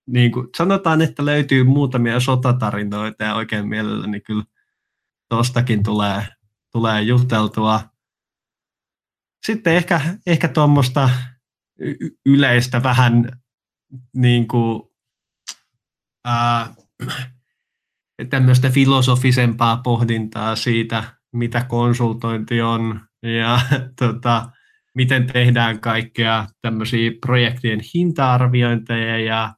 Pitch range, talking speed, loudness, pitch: 115-130 Hz, 80 wpm, -18 LUFS, 120 Hz